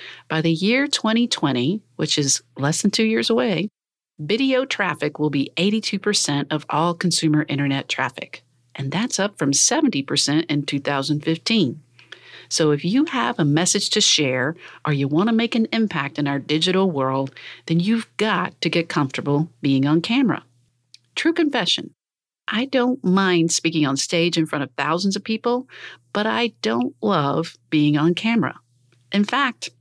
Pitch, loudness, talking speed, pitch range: 165 Hz, -20 LUFS, 160 wpm, 145-215 Hz